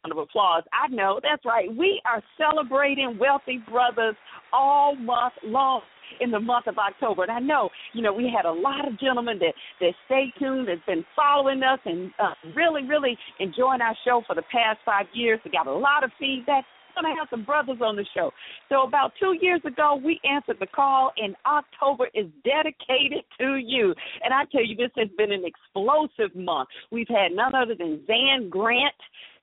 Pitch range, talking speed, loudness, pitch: 225-285 Hz, 195 wpm, -24 LUFS, 255 Hz